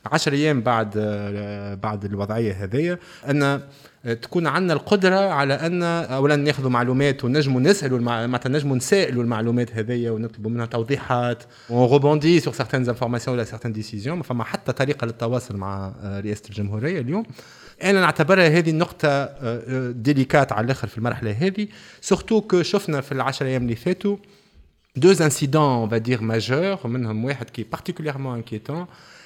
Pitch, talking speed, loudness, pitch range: 130 Hz, 140 wpm, -22 LUFS, 115-155 Hz